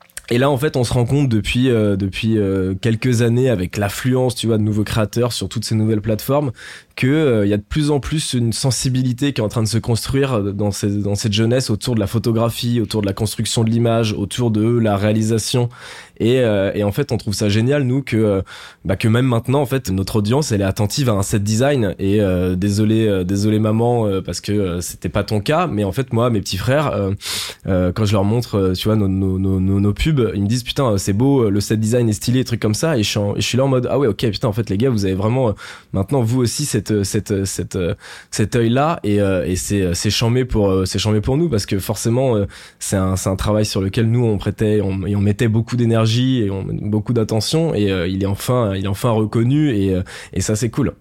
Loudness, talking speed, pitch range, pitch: -18 LUFS, 250 wpm, 100-125 Hz, 110 Hz